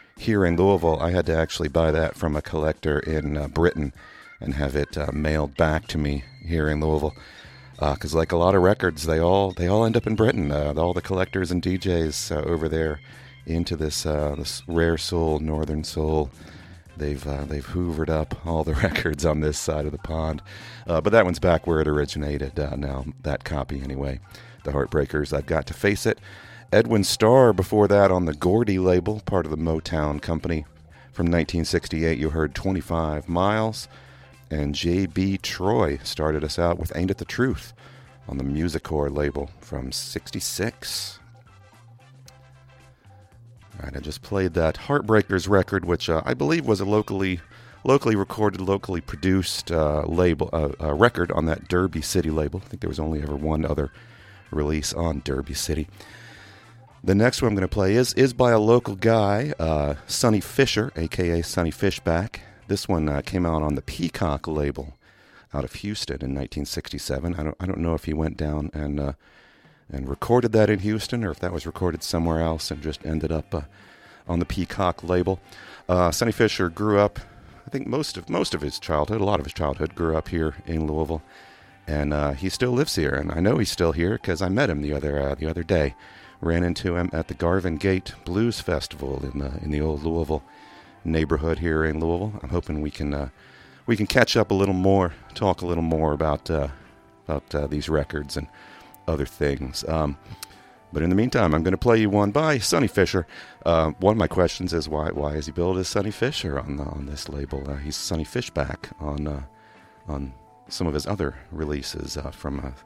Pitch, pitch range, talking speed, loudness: 85 Hz, 75-100 Hz, 200 wpm, -24 LUFS